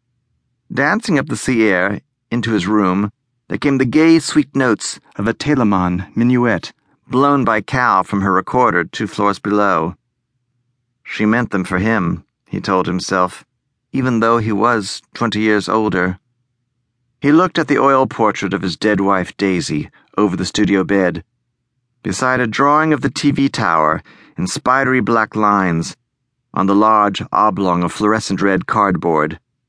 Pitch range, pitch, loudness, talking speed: 100-125 Hz, 110 Hz, -16 LUFS, 155 wpm